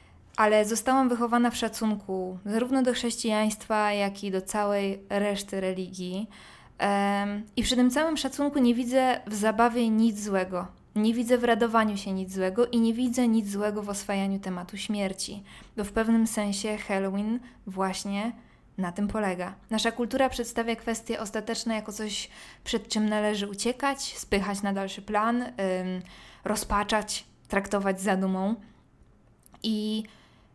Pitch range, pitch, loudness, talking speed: 200-230 Hz, 215 Hz, -28 LUFS, 140 wpm